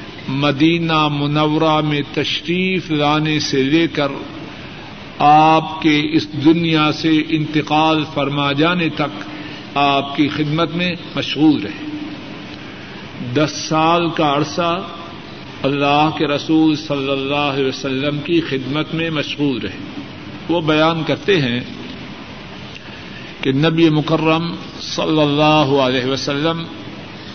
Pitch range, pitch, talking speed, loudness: 145-160 Hz, 150 Hz, 110 wpm, -16 LUFS